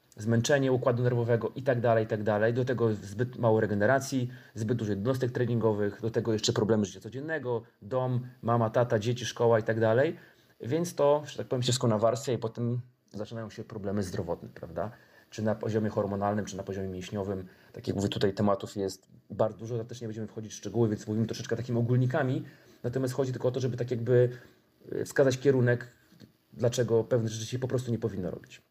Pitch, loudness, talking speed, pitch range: 115 Hz, -30 LUFS, 190 wpm, 110-125 Hz